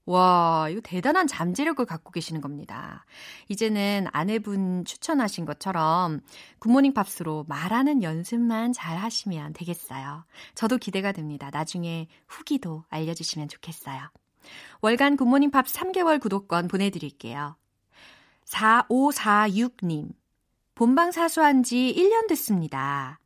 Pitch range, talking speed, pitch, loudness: 160-250 Hz, 270 characters per minute, 195 Hz, -25 LUFS